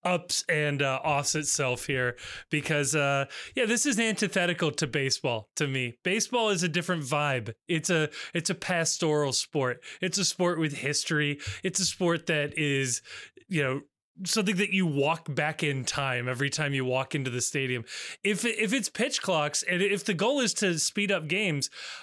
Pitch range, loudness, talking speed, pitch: 140-190 Hz, -28 LUFS, 180 wpm, 155 Hz